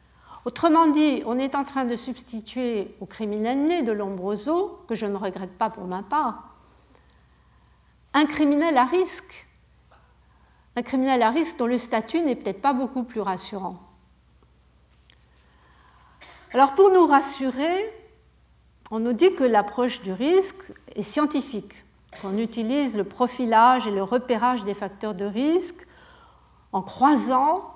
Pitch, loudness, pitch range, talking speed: 245 Hz, -23 LUFS, 200-290 Hz, 135 wpm